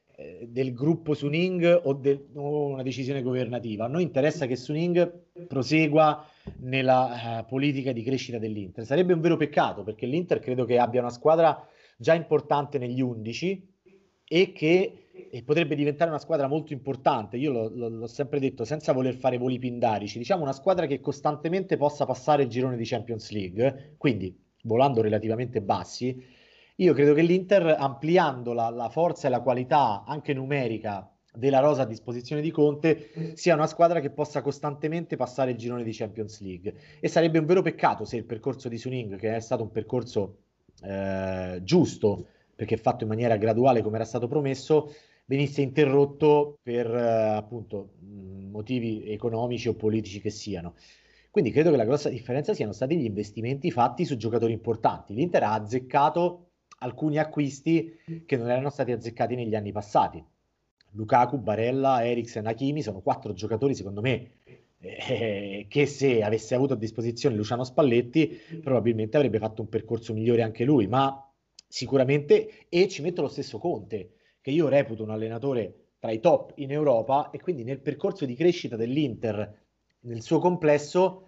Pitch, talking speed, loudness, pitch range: 130 Hz, 165 wpm, -26 LUFS, 115-150 Hz